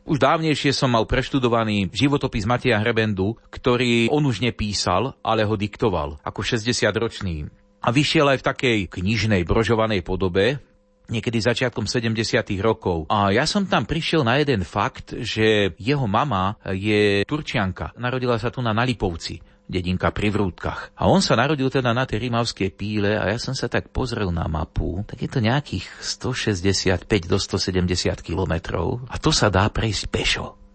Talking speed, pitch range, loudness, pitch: 160 wpm, 100-125 Hz, -22 LUFS, 110 Hz